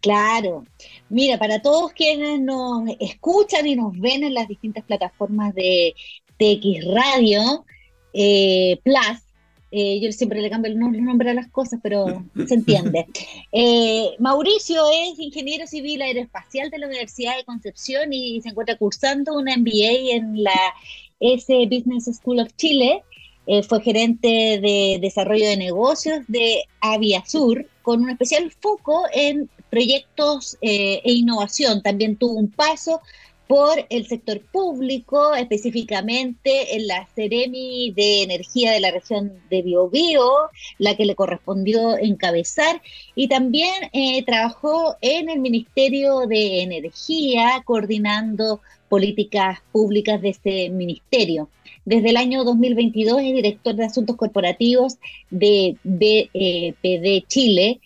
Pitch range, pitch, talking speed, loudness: 205-265 Hz, 230 Hz, 130 wpm, -19 LUFS